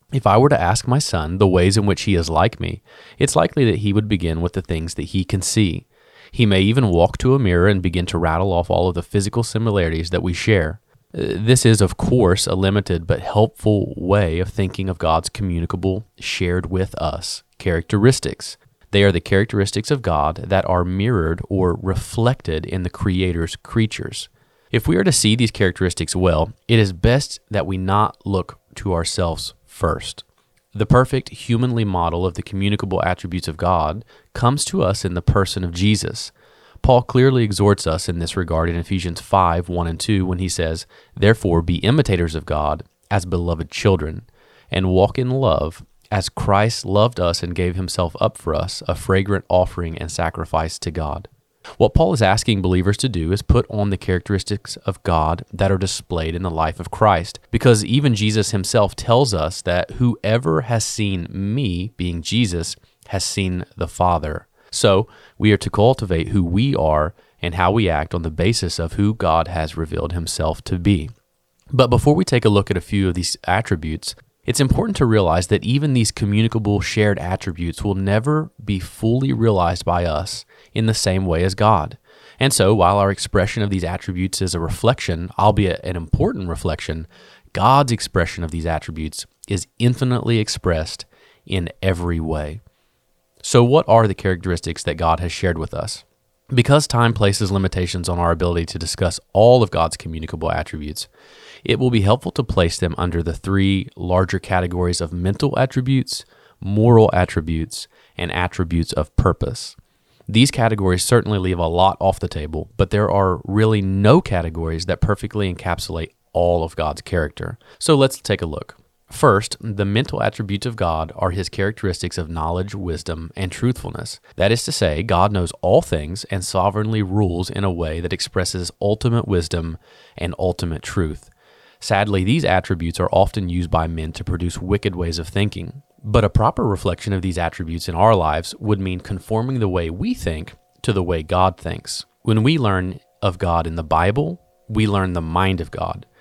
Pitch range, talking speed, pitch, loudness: 85-110 Hz, 180 wpm, 95 Hz, -19 LUFS